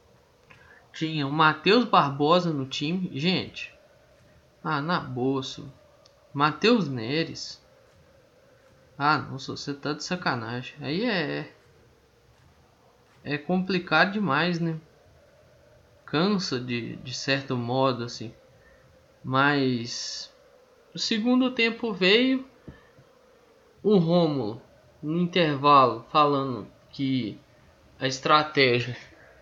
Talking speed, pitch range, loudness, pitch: 90 wpm, 130-180 Hz, -25 LUFS, 150 Hz